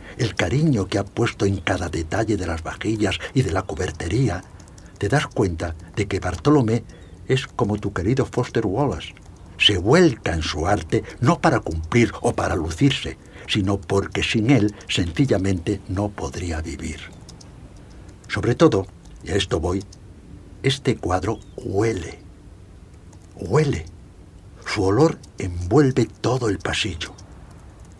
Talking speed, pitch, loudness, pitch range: 135 wpm, 95 Hz, -22 LUFS, 90-110 Hz